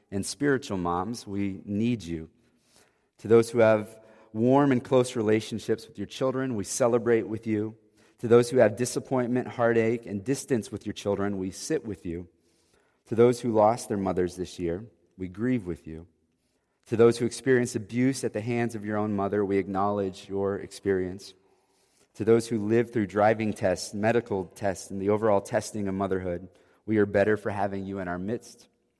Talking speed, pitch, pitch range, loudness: 180 wpm, 105 Hz, 95-115 Hz, -27 LUFS